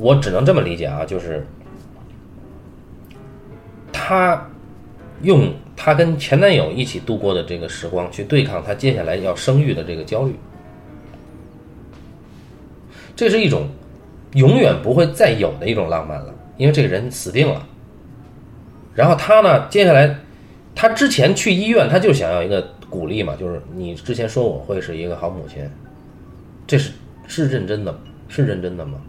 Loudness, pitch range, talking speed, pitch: -17 LUFS, 90-150 Hz, 230 characters per minute, 125 Hz